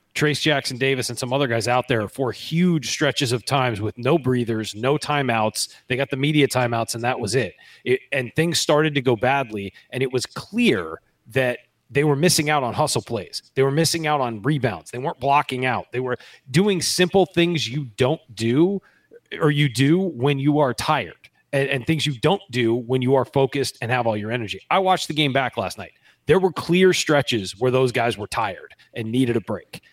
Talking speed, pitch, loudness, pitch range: 215 wpm, 135 Hz, -21 LUFS, 120-150 Hz